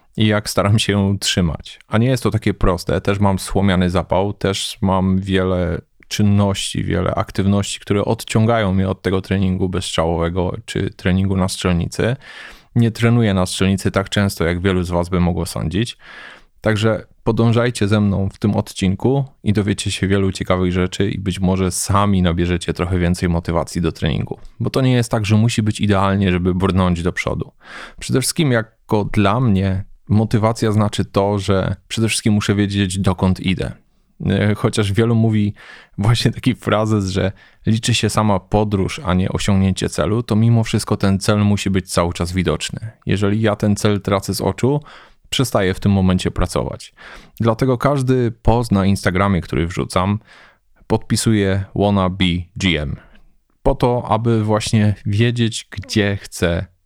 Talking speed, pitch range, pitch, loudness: 160 wpm, 95-110 Hz, 100 Hz, -18 LUFS